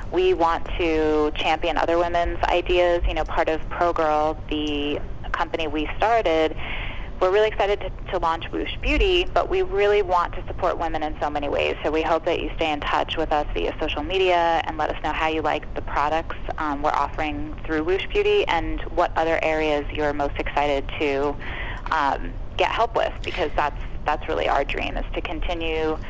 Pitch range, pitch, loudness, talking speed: 150-175 Hz, 160 Hz, -23 LUFS, 195 wpm